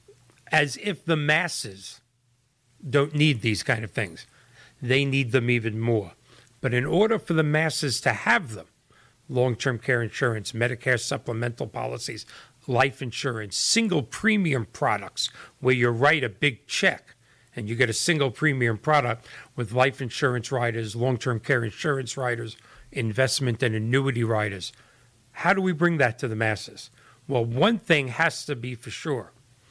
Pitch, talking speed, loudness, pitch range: 125 Hz, 160 wpm, -25 LUFS, 120-145 Hz